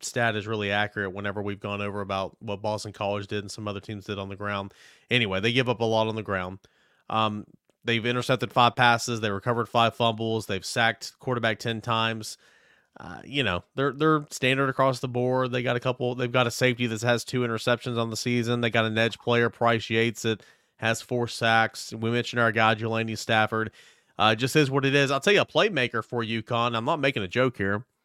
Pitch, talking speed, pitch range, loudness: 115 Hz, 225 wpm, 105-125 Hz, -26 LUFS